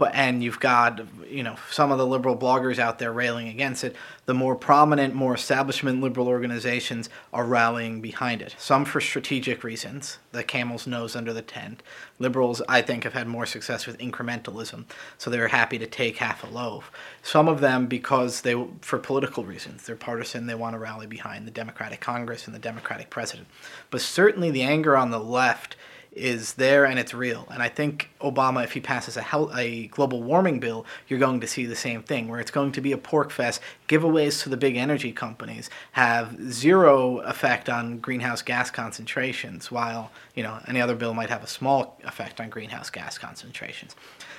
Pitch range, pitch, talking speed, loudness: 115-135 Hz, 125 Hz, 195 wpm, -25 LUFS